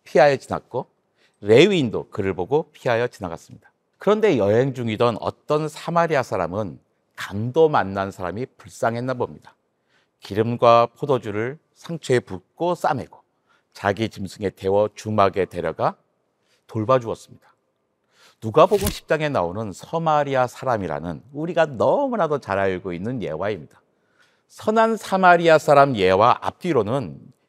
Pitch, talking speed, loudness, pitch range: 120 Hz, 305 characters per minute, -21 LUFS, 100-155 Hz